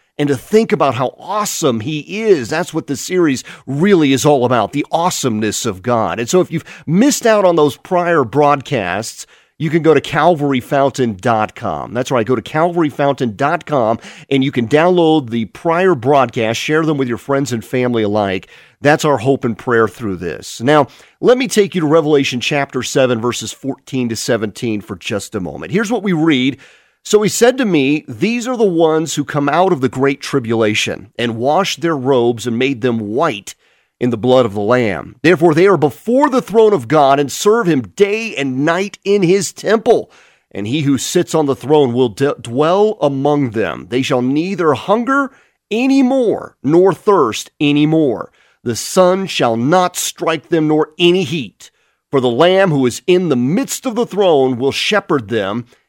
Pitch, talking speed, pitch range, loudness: 145 Hz, 190 wpm, 125-180 Hz, -15 LUFS